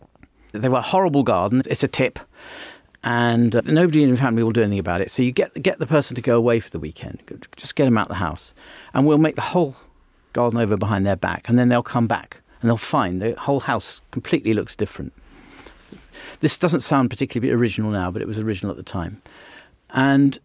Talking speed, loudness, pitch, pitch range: 220 wpm, -20 LUFS, 120 Hz, 110-135 Hz